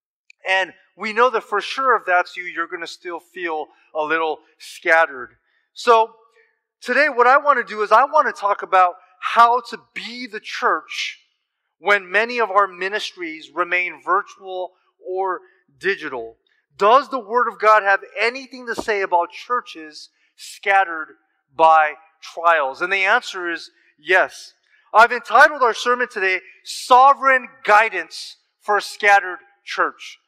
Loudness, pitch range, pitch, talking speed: -18 LUFS, 180-245 Hz, 205 Hz, 145 wpm